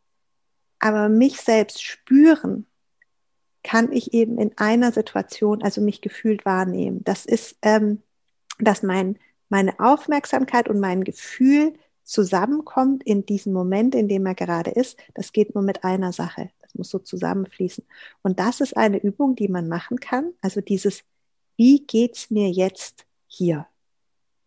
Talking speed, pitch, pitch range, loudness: 145 wpm, 215 Hz, 195-250 Hz, -21 LUFS